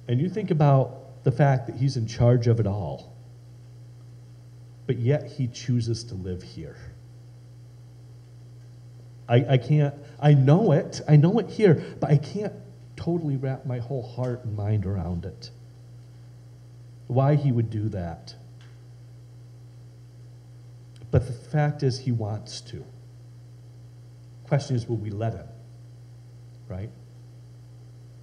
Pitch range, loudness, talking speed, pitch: 120-125 Hz, -24 LUFS, 130 wpm, 120 Hz